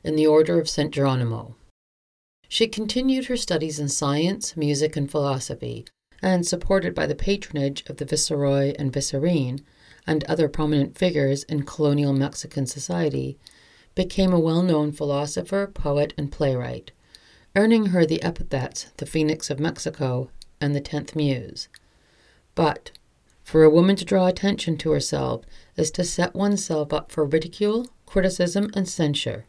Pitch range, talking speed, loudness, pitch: 140-180 Hz, 145 wpm, -23 LUFS, 155 Hz